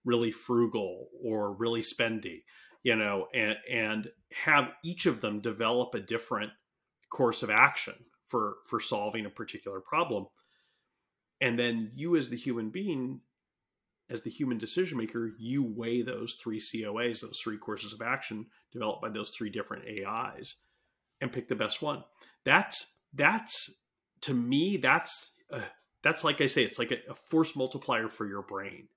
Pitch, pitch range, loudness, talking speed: 115 Hz, 110-130 Hz, -31 LUFS, 160 wpm